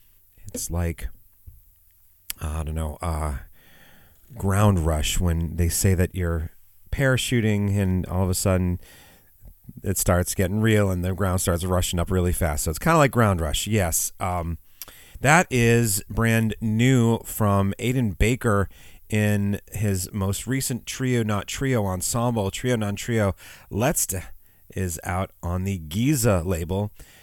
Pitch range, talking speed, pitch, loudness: 90-110 Hz, 145 wpm, 95 Hz, -23 LUFS